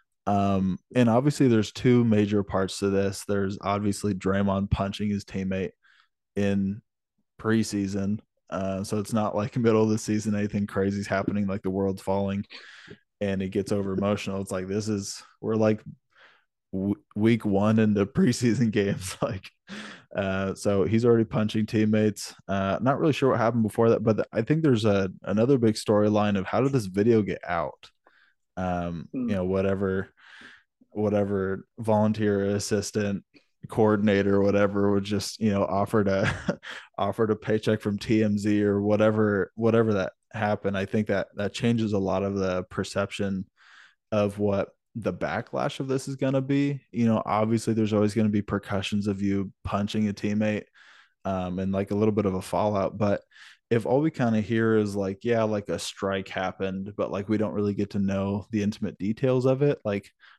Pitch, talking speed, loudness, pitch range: 105 Hz, 175 wpm, -26 LUFS, 100-110 Hz